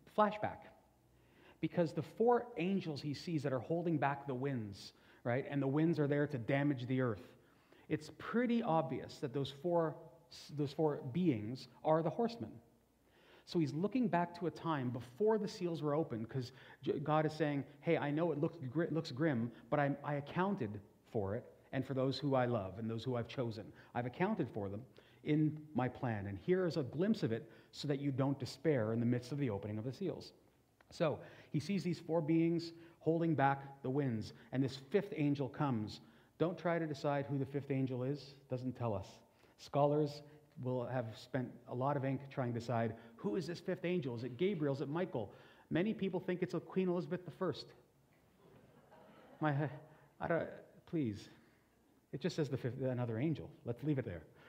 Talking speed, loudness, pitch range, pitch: 195 wpm, -39 LUFS, 125-165 Hz, 145 Hz